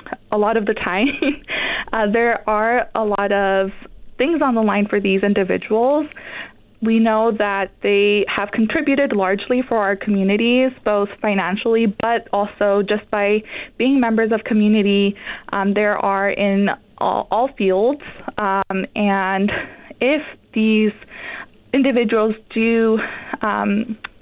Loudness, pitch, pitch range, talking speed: -18 LUFS, 215 Hz, 200-235 Hz, 130 wpm